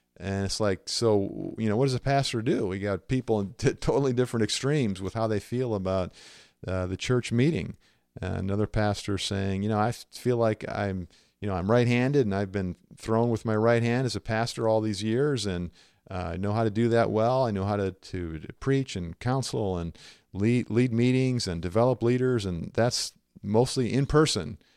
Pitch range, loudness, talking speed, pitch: 100-125 Hz, -27 LUFS, 210 wpm, 110 Hz